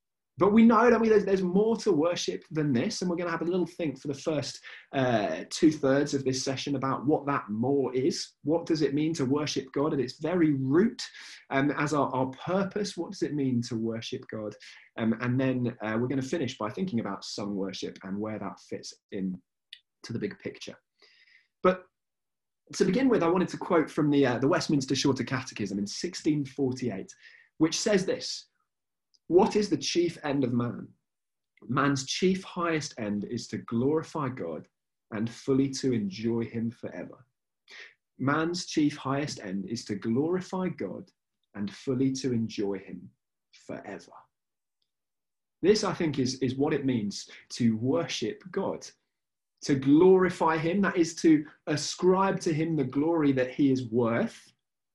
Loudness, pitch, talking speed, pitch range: -28 LUFS, 140 Hz, 170 wpm, 120-165 Hz